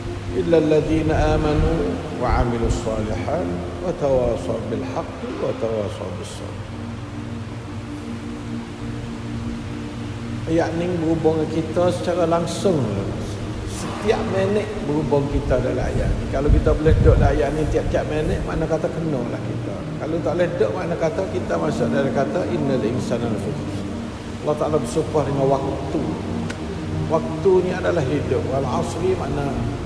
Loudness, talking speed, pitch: -22 LUFS, 130 wpm, 115 Hz